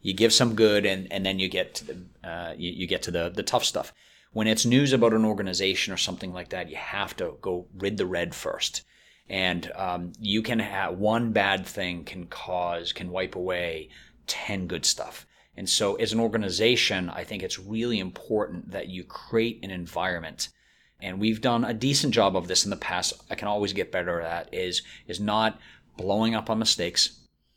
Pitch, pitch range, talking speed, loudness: 100 Hz, 90-110 Hz, 205 wpm, -26 LUFS